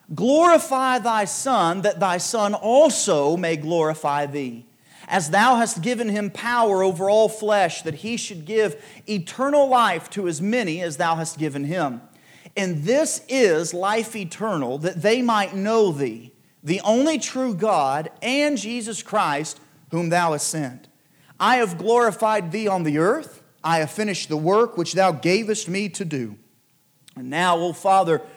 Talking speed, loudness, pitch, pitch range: 165 wpm, -21 LUFS, 195 Hz, 165-225 Hz